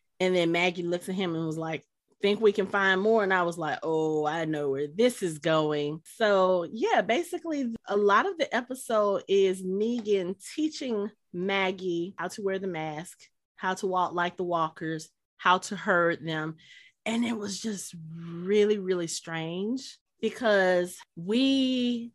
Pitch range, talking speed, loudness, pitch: 170-210 Hz, 165 wpm, -28 LUFS, 185 Hz